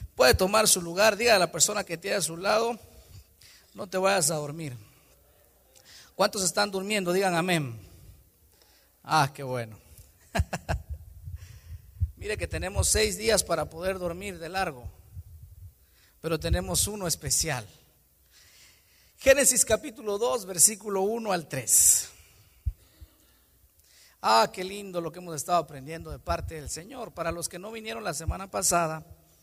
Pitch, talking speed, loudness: 165 Hz, 135 wpm, -26 LUFS